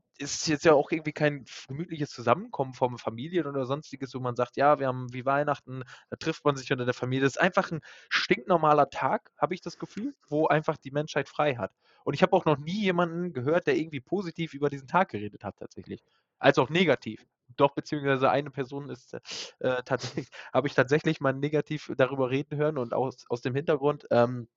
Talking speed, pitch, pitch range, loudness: 205 wpm, 140 Hz, 130-155 Hz, -28 LUFS